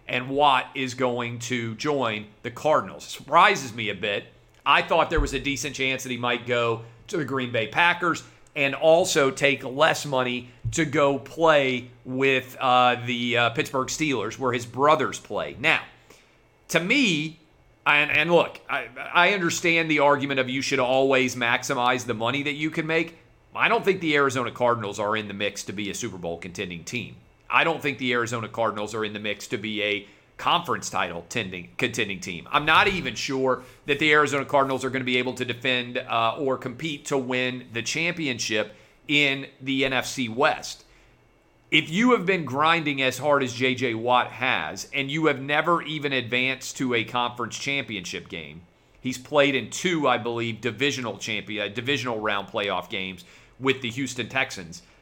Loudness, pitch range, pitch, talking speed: -24 LUFS, 120-145 Hz, 130 Hz, 180 wpm